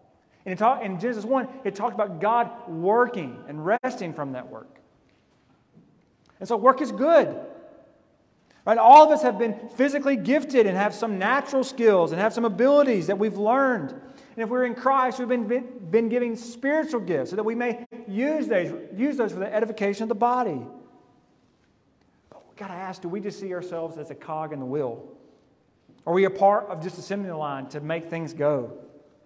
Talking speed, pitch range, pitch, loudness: 195 wpm, 185-250 Hz, 225 Hz, -23 LUFS